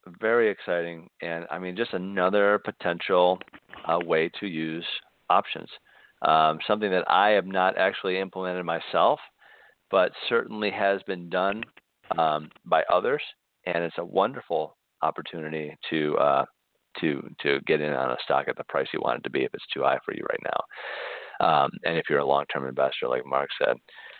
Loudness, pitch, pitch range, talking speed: -26 LUFS, 85 Hz, 80-95 Hz, 175 wpm